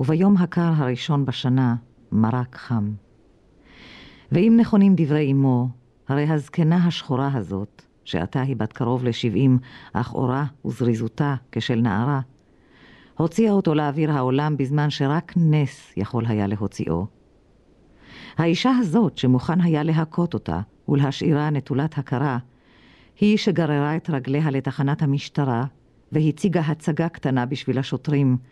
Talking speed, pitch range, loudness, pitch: 115 wpm, 125-155 Hz, -22 LUFS, 140 Hz